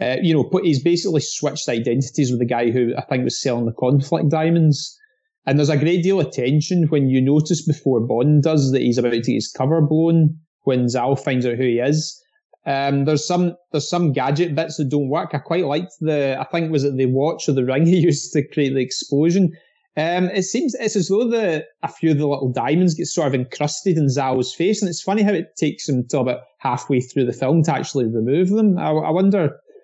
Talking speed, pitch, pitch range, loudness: 235 wpm, 150 Hz, 135-175 Hz, -19 LUFS